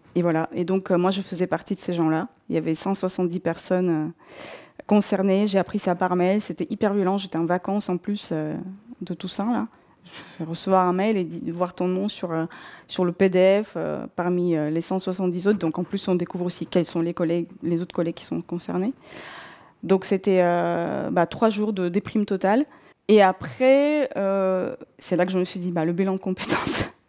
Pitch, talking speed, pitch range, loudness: 185 Hz, 215 wpm, 175-200 Hz, -24 LUFS